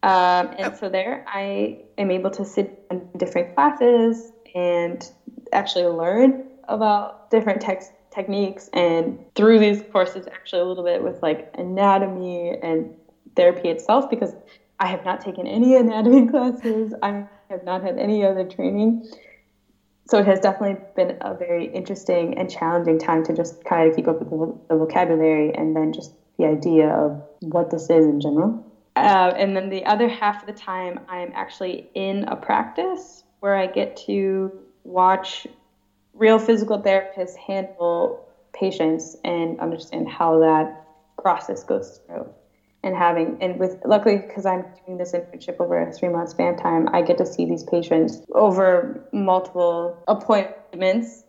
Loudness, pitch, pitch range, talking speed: -21 LUFS, 185 Hz, 170-210 Hz, 160 wpm